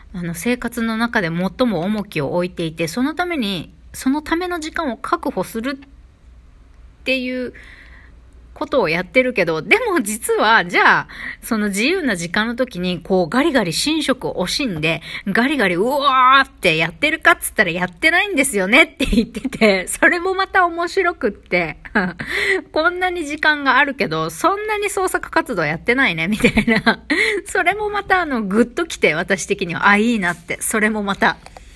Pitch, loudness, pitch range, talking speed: 245 Hz, -17 LUFS, 200-325 Hz, 335 characters per minute